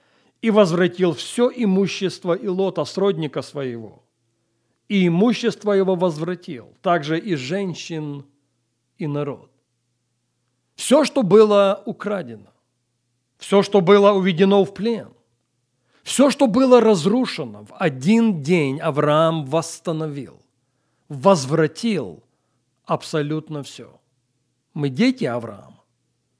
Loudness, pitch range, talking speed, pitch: -19 LUFS, 125-200 Hz, 95 wpm, 165 Hz